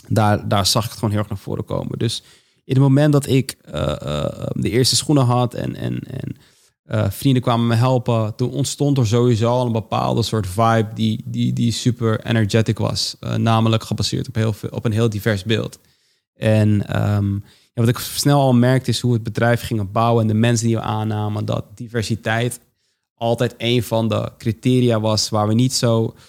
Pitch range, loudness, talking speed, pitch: 110-120 Hz, -19 LUFS, 205 wpm, 115 Hz